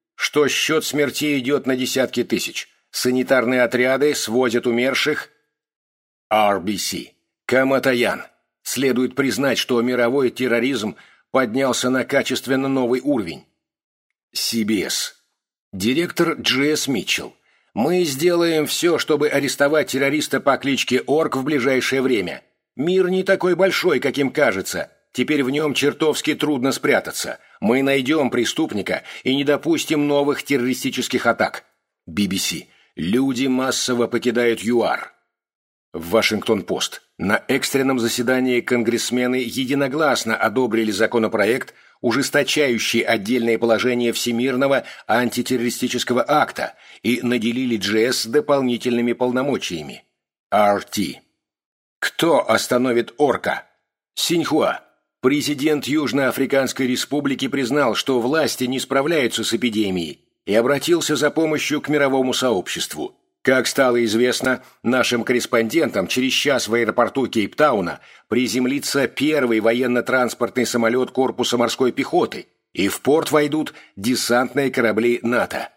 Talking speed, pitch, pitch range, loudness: 105 wpm, 130 Hz, 120-140 Hz, -19 LUFS